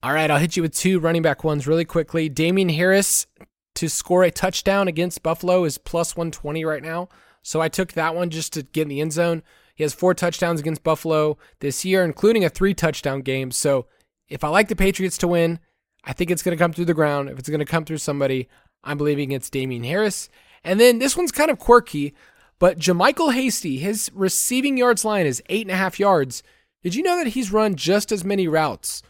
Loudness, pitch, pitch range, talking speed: -21 LUFS, 170 Hz, 155-190 Hz, 225 wpm